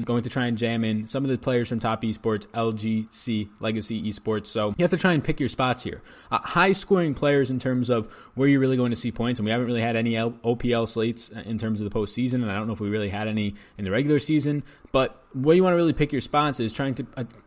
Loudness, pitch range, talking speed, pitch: -25 LUFS, 110-135 Hz, 270 wpm, 120 Hz